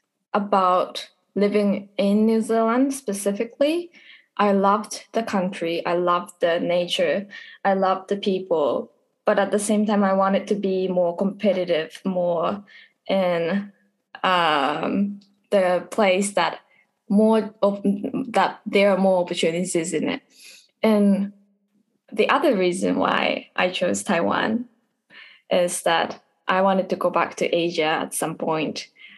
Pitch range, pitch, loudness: 185-215 Hz, 200 Hz, -22 LUFS